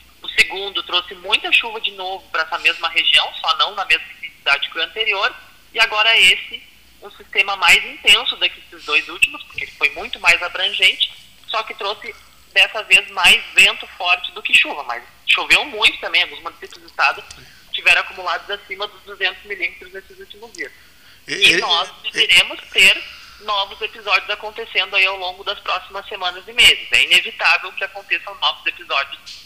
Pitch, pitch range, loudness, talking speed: 195 Hz, 180-215 Hz, -15 LUFS, 175 wpm